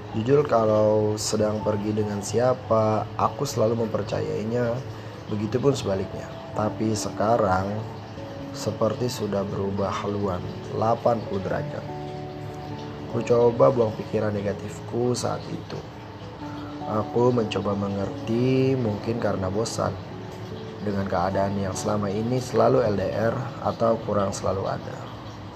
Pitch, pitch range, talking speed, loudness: 110 Hz, 100-120 Hz, 105 wpm, -25 LUFS